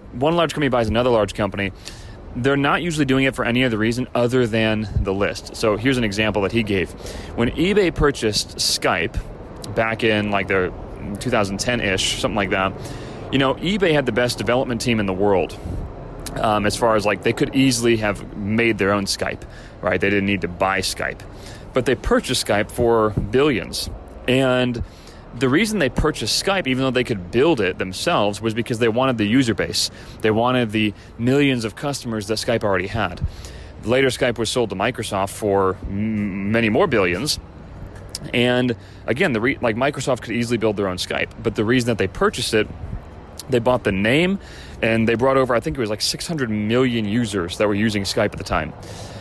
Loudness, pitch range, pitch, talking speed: -20 LUFS, 100-125 Hz, 110 Hz, 195 wpm